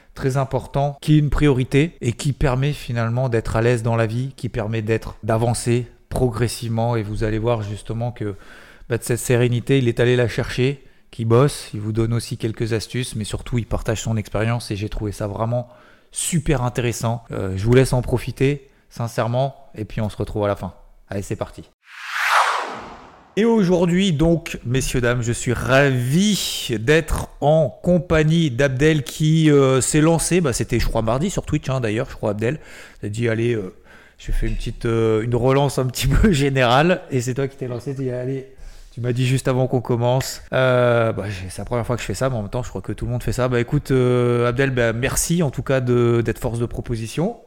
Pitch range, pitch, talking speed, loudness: 115-135 Hz, 125 Hz, 215 wpm, -20 LUFS